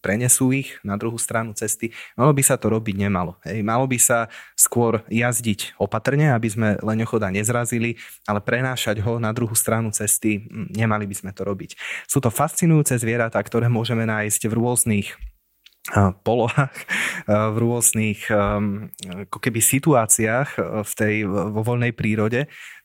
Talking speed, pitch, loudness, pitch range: 140 wpm, 115 Hz, -21 LUFS, 105-120 Hz